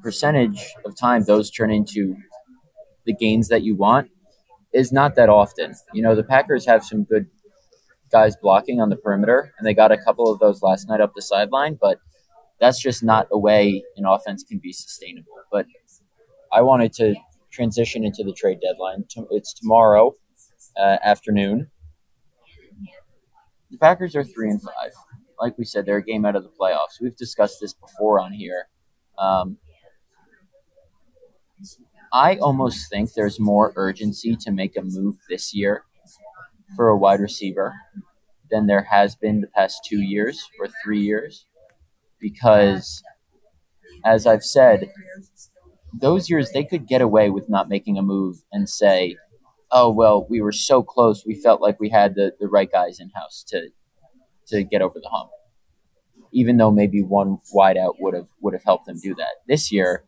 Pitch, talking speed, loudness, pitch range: 110 Hz, 170 wpm, -19 LUFS, 100-135 Hz